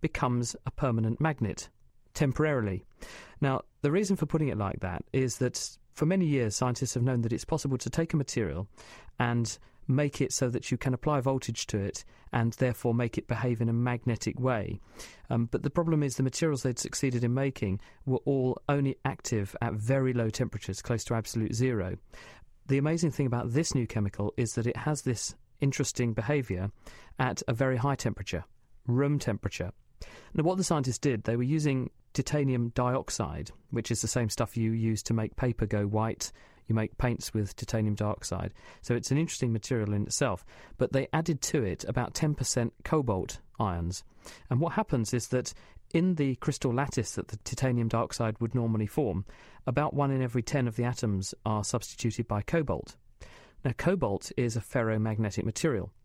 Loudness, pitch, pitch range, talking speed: -31 LUFS, 120 Hz, 110-135 Hz, 180 wpm